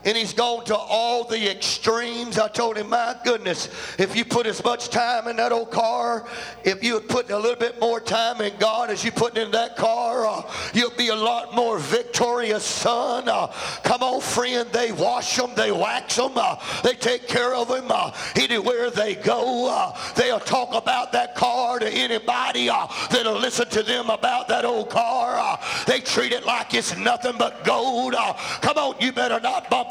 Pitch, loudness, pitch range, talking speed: 235 Hz, -22 LUFS, 225-245 Hz, 200 wpm